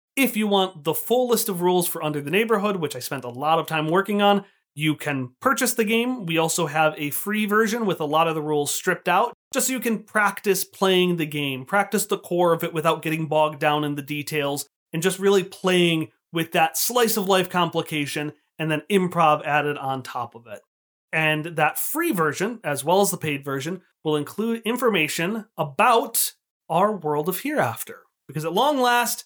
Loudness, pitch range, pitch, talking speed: -22 LUFS, 155-205 Hz, 170 Hz, 205 wpm